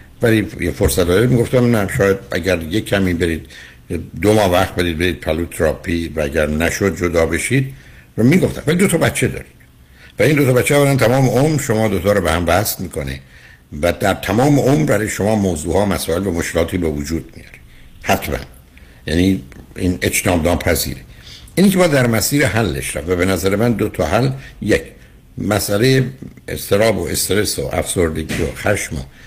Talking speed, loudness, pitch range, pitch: 175 wpm, -16 LUFS, 80-115 Hz, 95 Hz